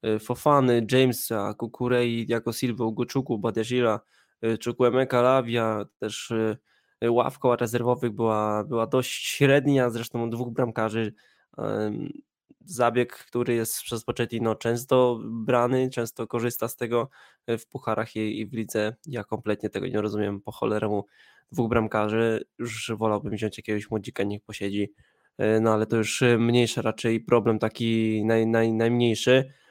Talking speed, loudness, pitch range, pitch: 130 wpm, -26 LUFS, 110-120 Hz, 115 Hz